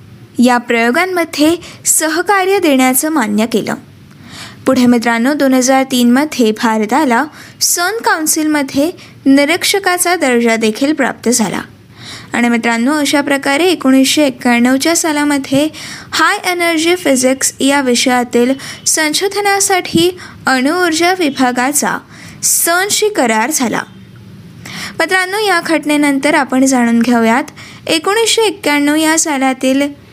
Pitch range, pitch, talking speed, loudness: 250-335 Hz, 285 Hz, 95 wpm, -12 LUFS